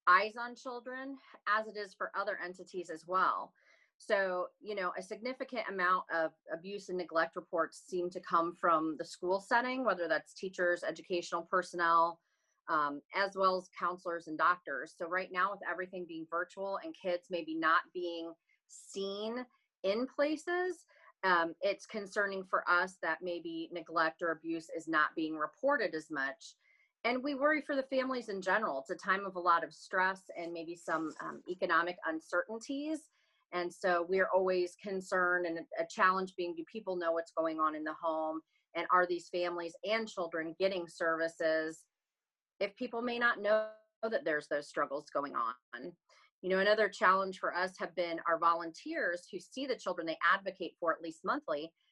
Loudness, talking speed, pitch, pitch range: -35 LUFS, 175 wpm, 180 Hz, 165-200 Hz